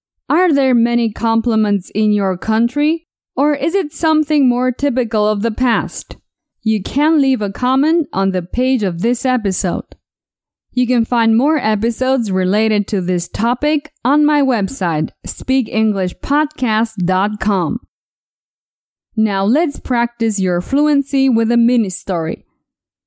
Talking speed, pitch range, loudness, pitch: 125 wpm, 205-270 Hz, -16 LUFS, 235 Hz